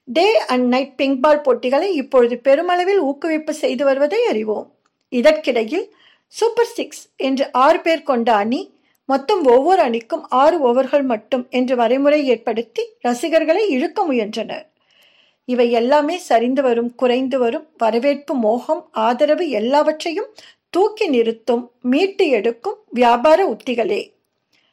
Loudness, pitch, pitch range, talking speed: -17 LUFS, 275 Hz, 245-335 Hz, 115 wpm